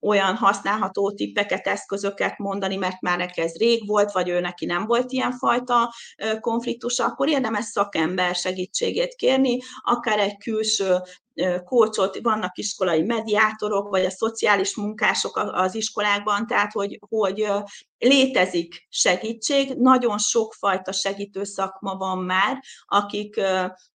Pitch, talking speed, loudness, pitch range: 205 Hz, 125 wpm, -23 LUFS, 190-230 Hz